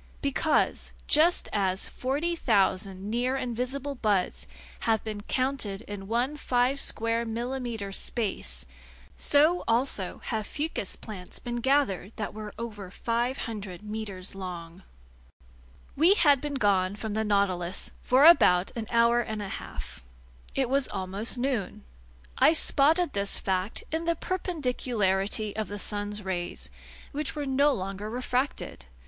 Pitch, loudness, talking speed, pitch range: 220 Hz, -27 LUFS, 135 wpm, 190-265 Hz